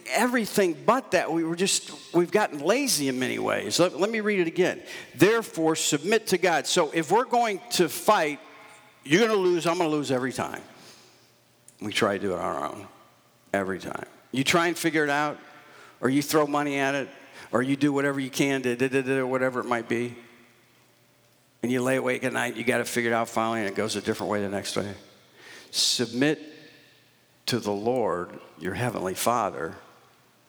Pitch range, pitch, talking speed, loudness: 120-175 Hz, 145 Hz, 195 wpm, -25 LUFS